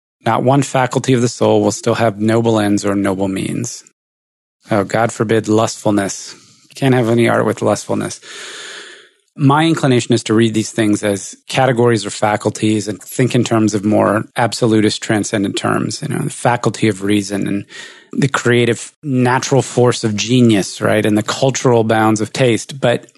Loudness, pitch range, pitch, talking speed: -15 LUFS, 105-125 Hz, 115 Hz, 170 wpm